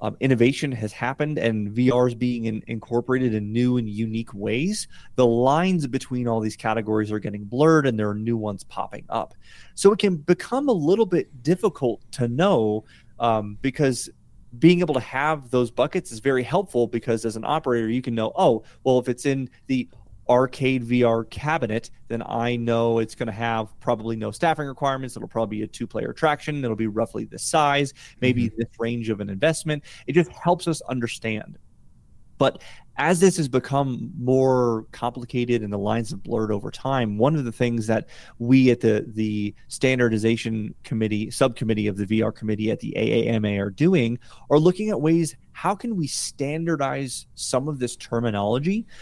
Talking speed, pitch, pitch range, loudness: 180 wpm, 120 Hz, 115-140 Hz, -23 LUFS